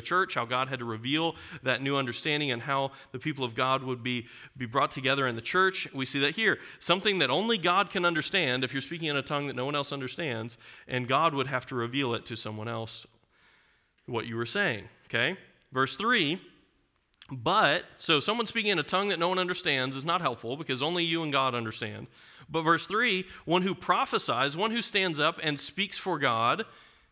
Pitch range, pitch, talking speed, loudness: 125-170 Hz, 140 Hz, 210 wpm, -28 LUFS